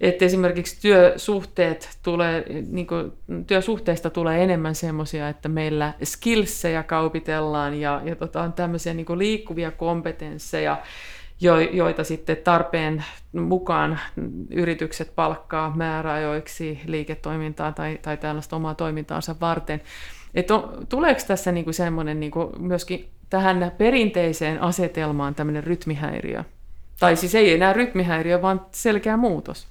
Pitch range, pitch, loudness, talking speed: 155-180 Hz, 165 Hz, -23 LUFS, 115 wpm